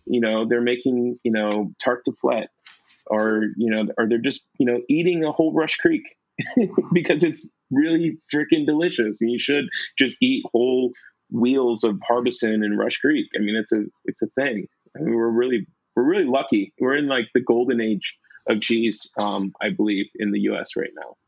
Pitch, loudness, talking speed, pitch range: 120 Hz, -22 LUFS, 195 wpm, 110-155 Hz